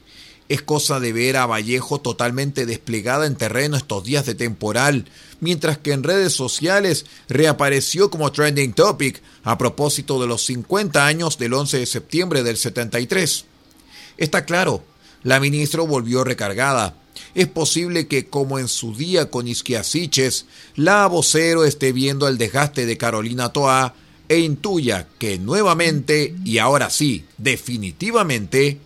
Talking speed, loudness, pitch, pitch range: 140 wpm, -19 LUFS, 140 Hz, 120-155 Hz